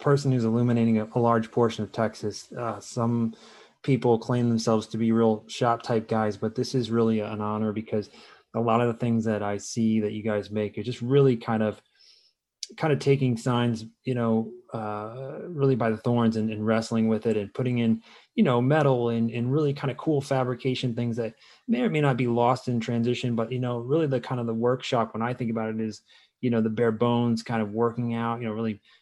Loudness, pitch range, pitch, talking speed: -26 LUFS, 110-125 Hz, 115 Hz, 225 wpm